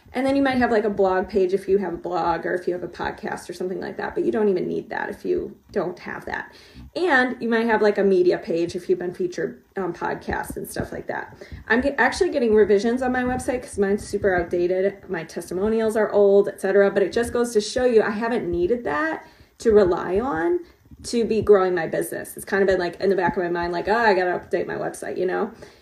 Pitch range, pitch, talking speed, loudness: 190-240 Hz, 205 Hz, 250 wpm, -22 LUFS